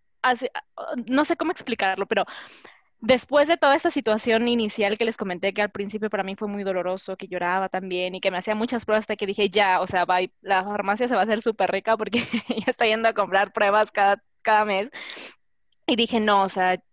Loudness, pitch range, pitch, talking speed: -23 LUFS, 195-235 Hz, 215 Hz, 215 wpm